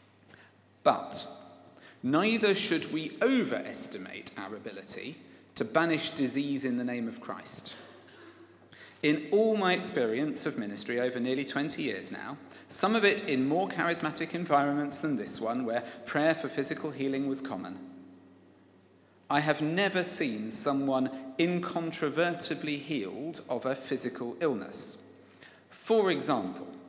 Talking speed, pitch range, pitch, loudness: 125 wpm, 125-170 Hz, 145 Hz, -31 LUFS